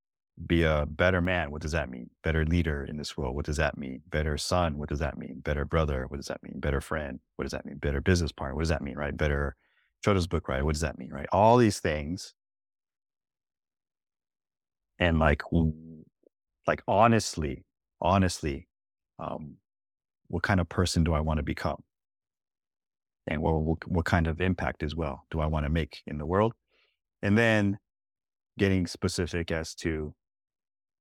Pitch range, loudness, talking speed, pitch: 75-90 Hz, -29 LUFS, 180 wpm, 80 Hz